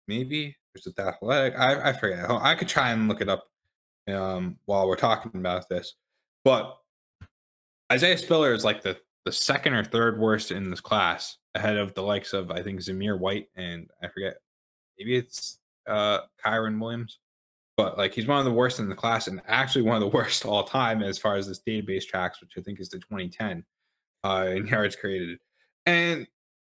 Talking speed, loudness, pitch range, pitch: 195 wpm, -26 LUFS, 95-120 Hz, 105 Hz